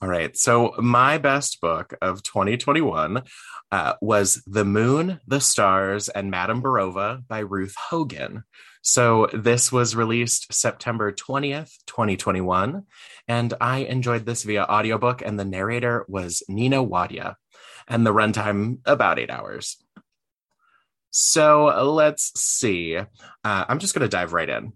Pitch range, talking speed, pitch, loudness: 100-130 Hz, 135 wpm, 115 Hz, -21 LUFS